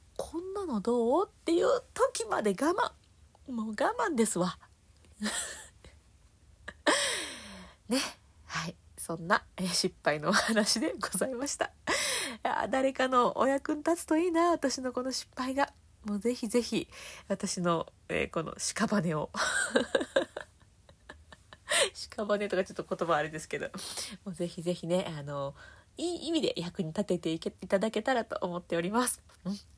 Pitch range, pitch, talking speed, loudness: 180-275 Hz, 210 Hz, 250 characters per minute, -31 LUFS